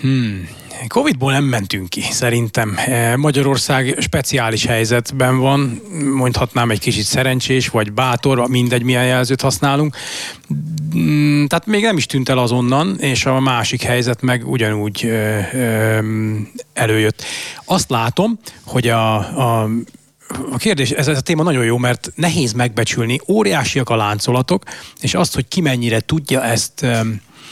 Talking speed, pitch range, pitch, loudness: 135 wpm, 115-140 Hz, 125 Hz, -16 LUFS